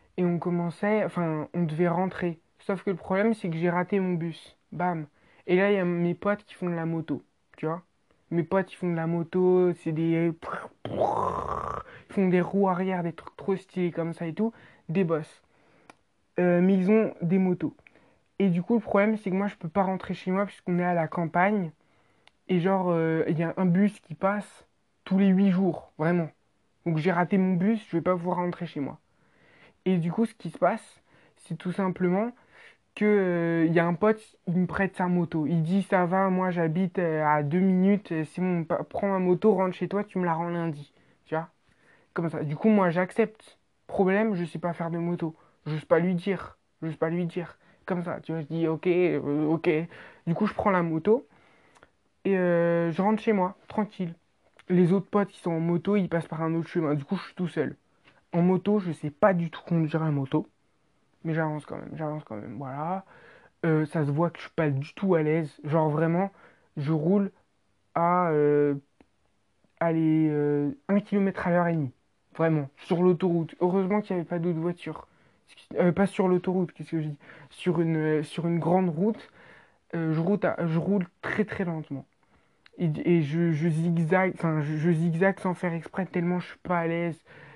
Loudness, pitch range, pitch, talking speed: -27 LUFS, 160-190 Hz, 175 Hz, 210 wpm